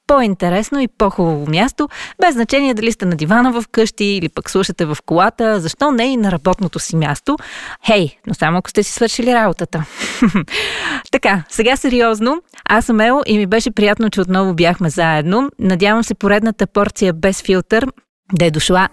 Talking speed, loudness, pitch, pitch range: 175 wpm, -15 LUFS, 205 Hz, 185-235 Hz